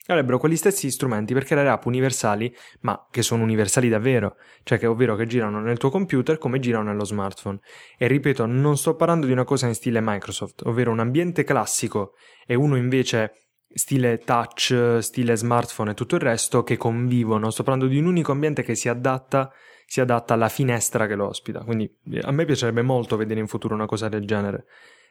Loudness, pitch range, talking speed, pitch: -22 LUFS, 110-135 Hz, 195 wpm, 120 Hz